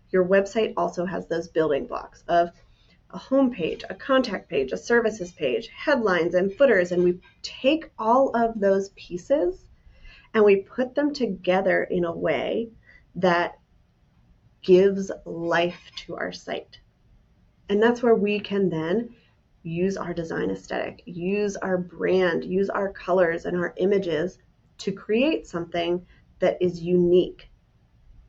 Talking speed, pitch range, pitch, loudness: 140 wpm, 175-220 Hz, 190 Hz, -24 LUFS